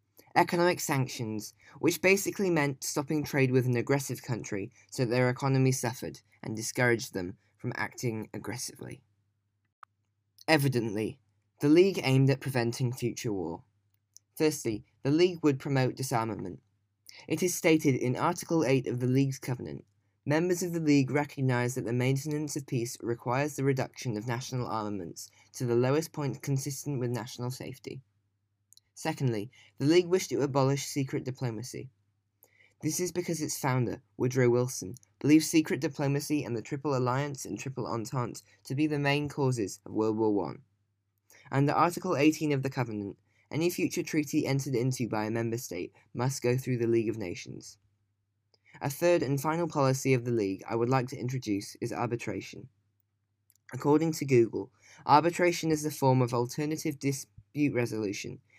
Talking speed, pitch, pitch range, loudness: 155 wpm, 125 Hz, 110-145 Hz, -30 LUFS